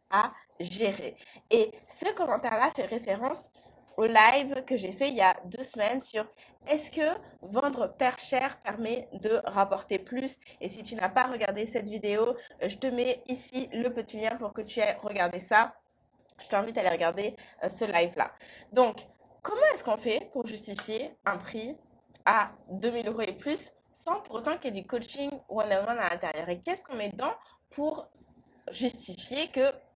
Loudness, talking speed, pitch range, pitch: -30 LUFS, 175 wpm, 210-265 Hz, 235 Hz